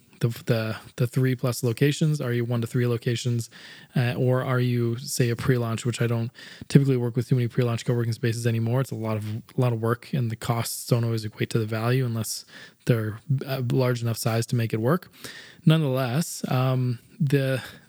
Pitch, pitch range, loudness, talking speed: 125 Hz, 115-130 Hz, -25 LUFS, 200 wpm